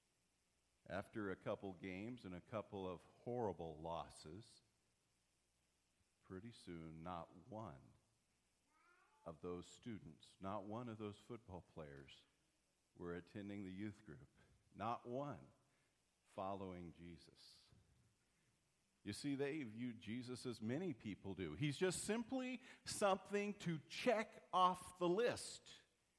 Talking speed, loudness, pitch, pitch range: 115 wpm, -47 LUFS, 100 Hz, 85-125 Hz